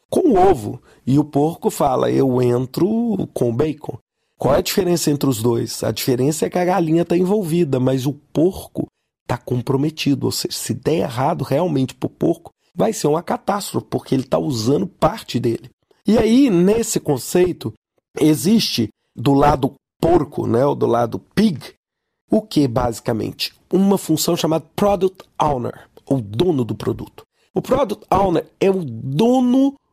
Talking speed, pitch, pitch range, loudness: 165 wpm, 155 Hz, 130-195 Hz, -19 LUFS